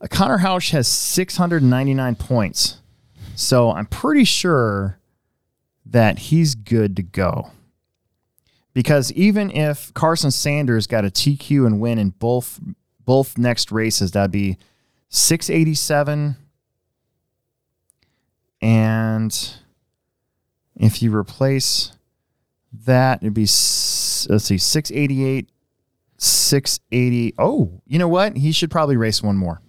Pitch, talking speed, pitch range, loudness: 125 Hz, 110 wpm, 110-145 Hz, -18 LUFS